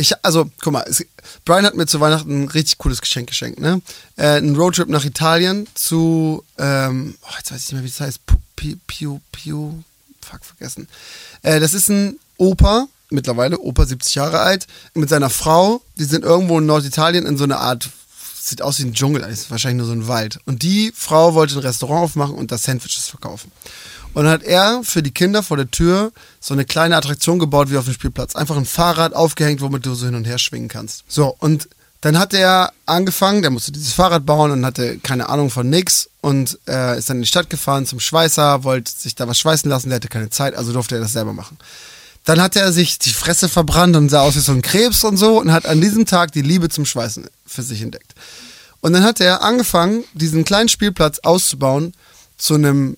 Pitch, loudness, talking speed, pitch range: 150 Hz, -15 LUFS, 220 wpm, 130-170 Hz